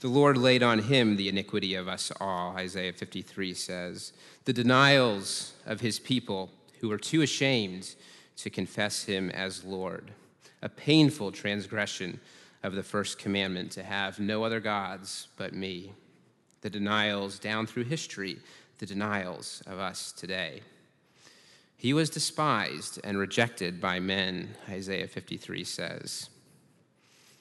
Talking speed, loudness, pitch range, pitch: 135 wpm, -30 LUFS, 95-115 Hz, 100 Hz